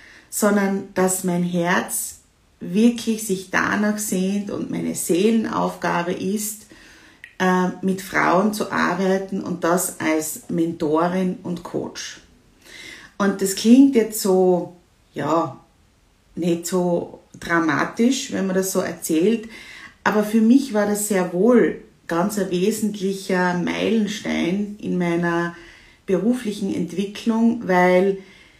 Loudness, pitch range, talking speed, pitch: -21 LUFS, 175-210 Hz, 110 wpm, 190 Hz